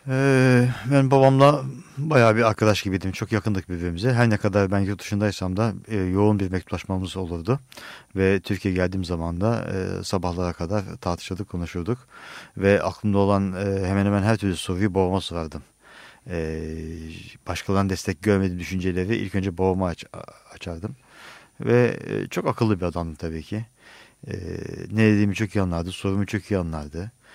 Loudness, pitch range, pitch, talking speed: -23 LUFS, 90-110 Hz, 100 Hz, 155 wpm